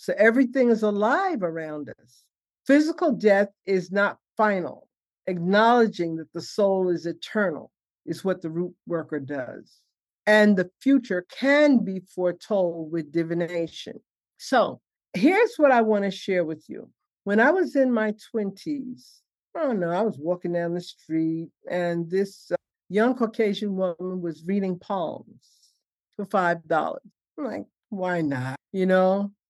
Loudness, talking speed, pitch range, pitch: -24 LUFS, 145 wpm, 175-220 Hz, 190 Hz